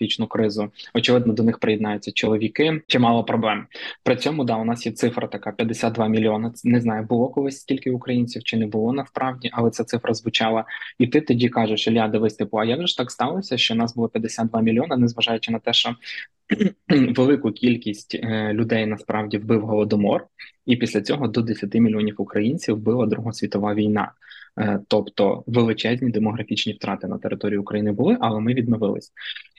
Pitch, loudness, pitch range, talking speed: 115 Hz, -22 LUFS, 110-125 Hz, 160 wpm